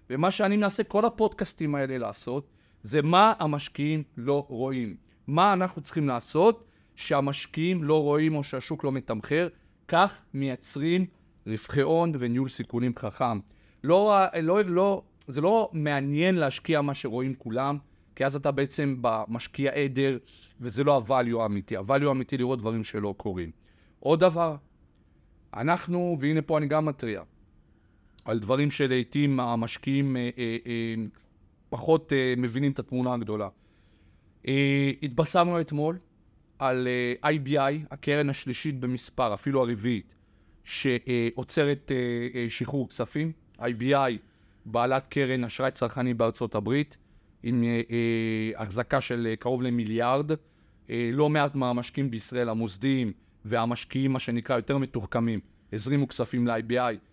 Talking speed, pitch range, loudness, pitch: 125 wpm, 115-145 Hz, -27 LUFS, 130 Hz